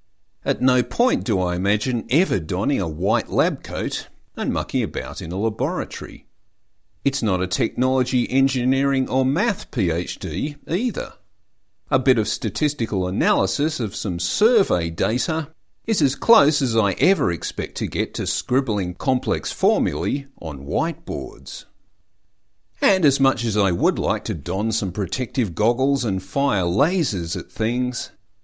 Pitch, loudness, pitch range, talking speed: 110 Hz, -22 LUFS, 95-130 Hz, 145 wpm